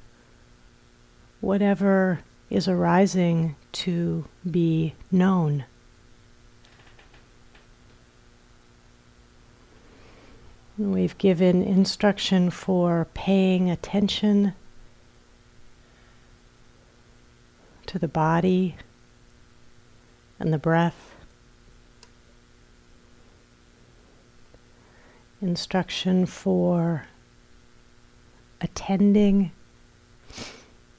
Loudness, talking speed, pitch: -23 LUFS, 45 wpm, 170 Hz